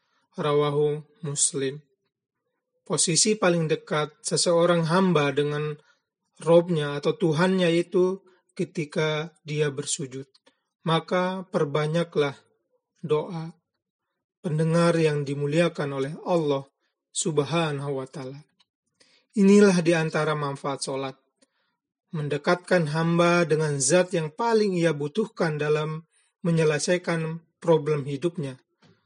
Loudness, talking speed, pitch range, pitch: -24 LUFS, 90 wpm, 150-180 Hz, 165 Hz